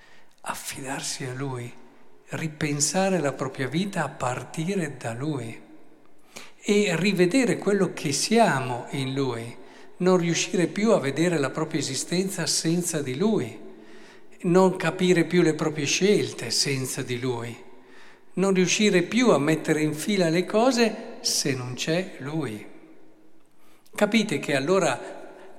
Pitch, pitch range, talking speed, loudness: 160 Hz, 140-185 Hz, 125 wpm, -24 LUFS